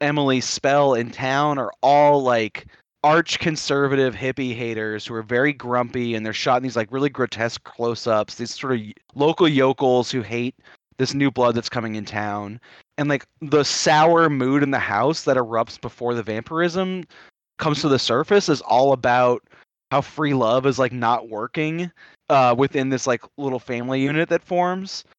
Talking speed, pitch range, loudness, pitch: 175 wpm, 120-145 Hz, -21 LUFS, 130 Hz